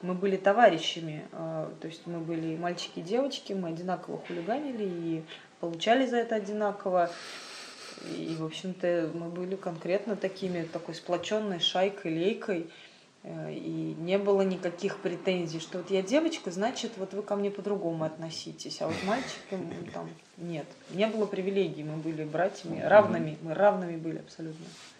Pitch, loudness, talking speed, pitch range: 180 Hz, -31 LUFS, 145 wpm, 165-200 Hz